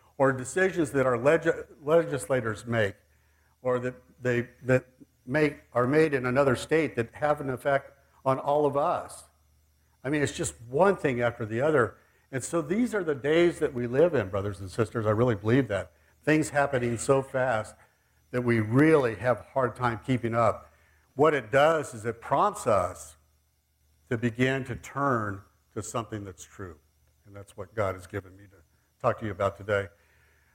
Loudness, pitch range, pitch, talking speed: -27 LUFS, 100-140 Hz, 120 Hz, 180 wpm